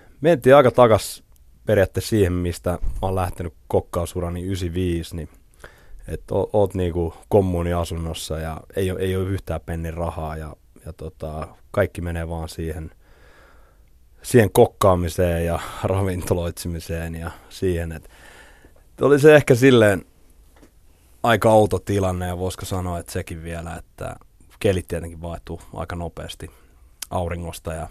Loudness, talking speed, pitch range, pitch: -21 LUFS, 130 wpm, 80-95 Hz, 85 Hz